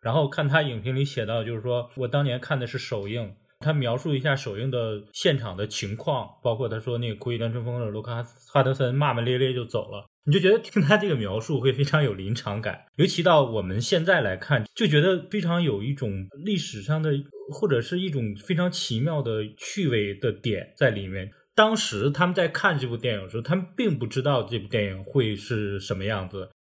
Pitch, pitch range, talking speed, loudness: 125 Hz, 110-155 Hz, 320 characters per minute, -25 LUFS